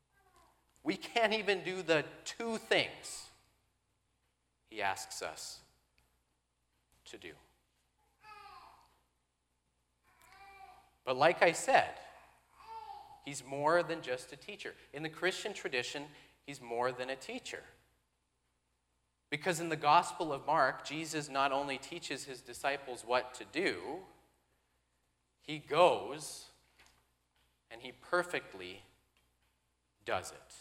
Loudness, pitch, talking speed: -35 LUFS, 125 Hz, 105 wpm